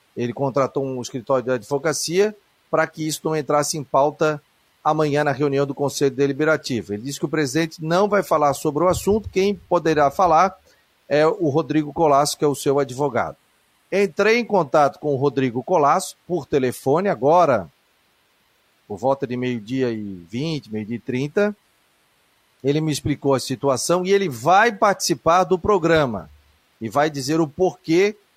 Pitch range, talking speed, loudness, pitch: 135-170 Hz, 165 wpm, -20 LUFS, 150 Hz